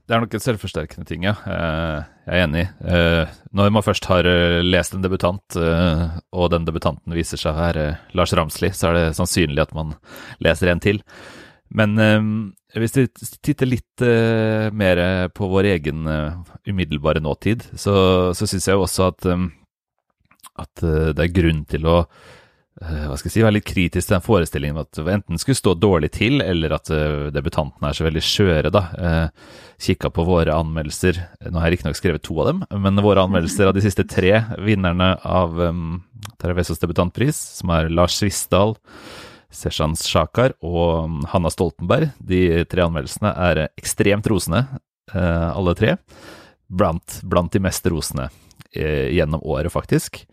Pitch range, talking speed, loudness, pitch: 80-100 Hz, 160 wpm, -19 LUFS, 90 Hz